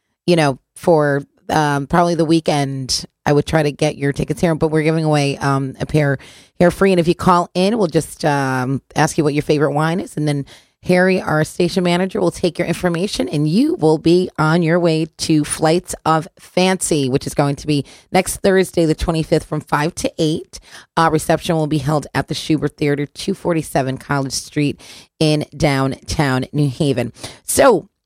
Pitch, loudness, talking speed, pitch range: 155 Hz, -17 LUFS, 200 wpm, 145-170 Hz